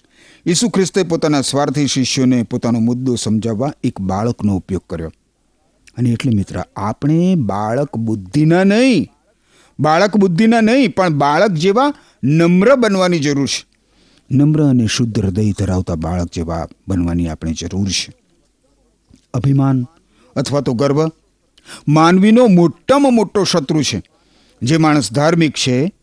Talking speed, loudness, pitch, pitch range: 120 wpm, -15 LUFS, 140 Hz, 115-175 Hz